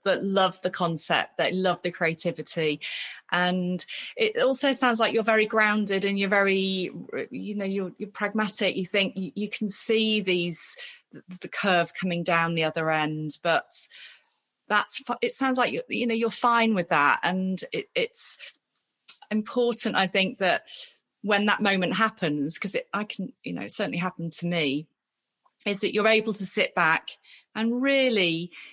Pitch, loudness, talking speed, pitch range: 200 Hz, -25 LUFS, 165 wpm, 180-225 Hz